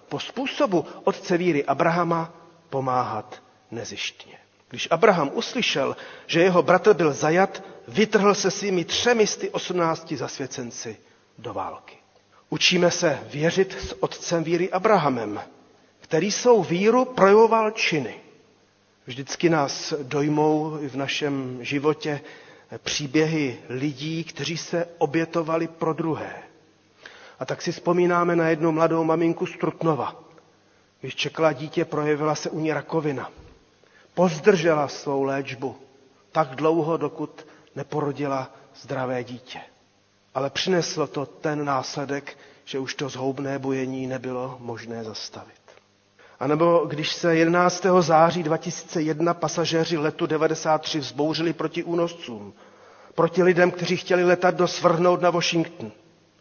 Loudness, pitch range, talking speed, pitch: -23 LUFS, 140-170 Hz, 120 wpm, 160 Hz